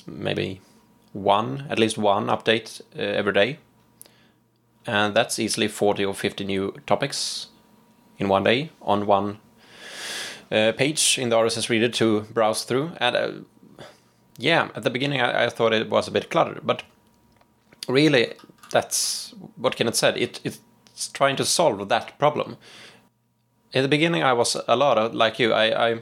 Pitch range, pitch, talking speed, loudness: 105-120 Hz, 115 Hz, 165 wpm, -22 LUFS